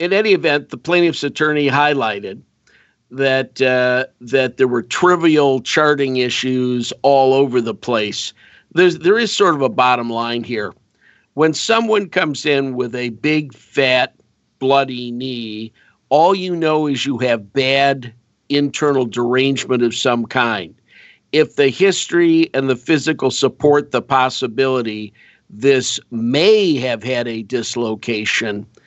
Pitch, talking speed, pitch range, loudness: 130 Hz, 135 wpm, 125-150 Hz, -16 LUFS